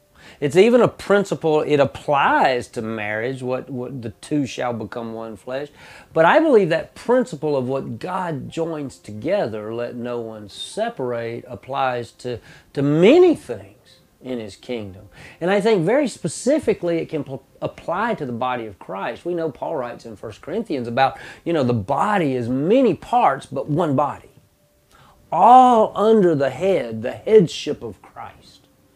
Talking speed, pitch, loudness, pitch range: 160 wpm, 135 Hz, -20 LUFS, 120-175 Hz